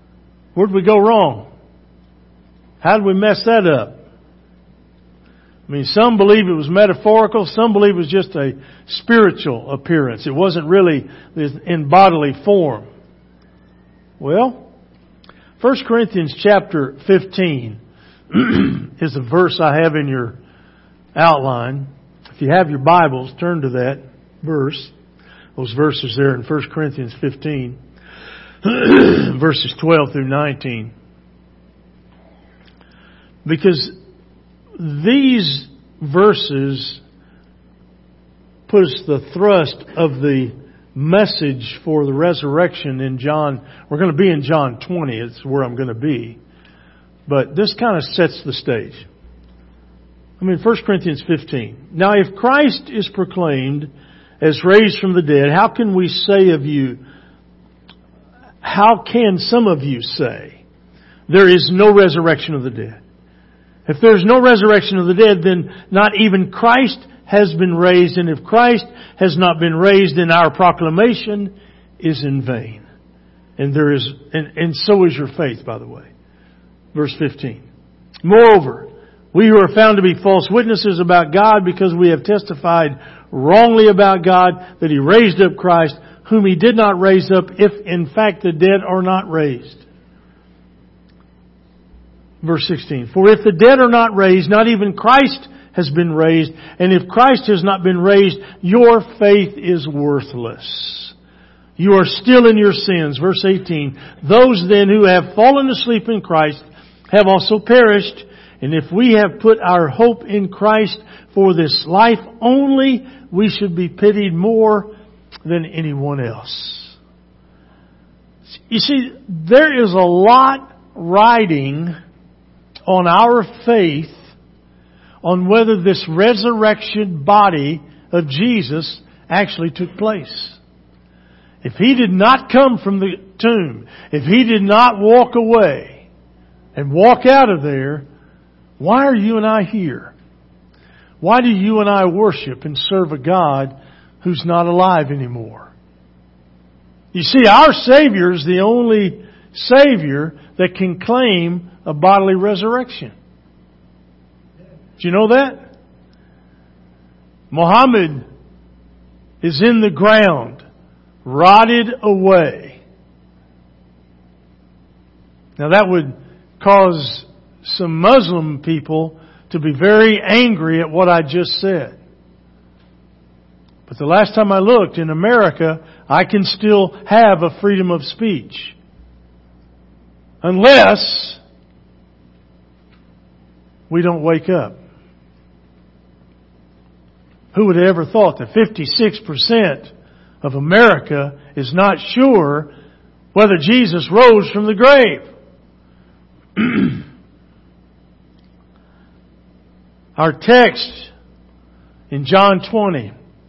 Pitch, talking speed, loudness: 165 Hz, 125 wpm, -13 LUFS